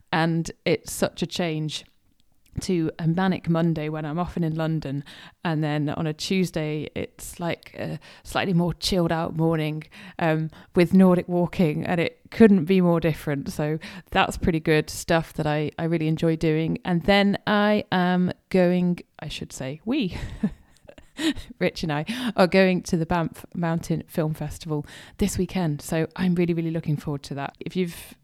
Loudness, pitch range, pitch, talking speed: -24 LUFS, 155-180 Hz, 165 Hz, 170 wpm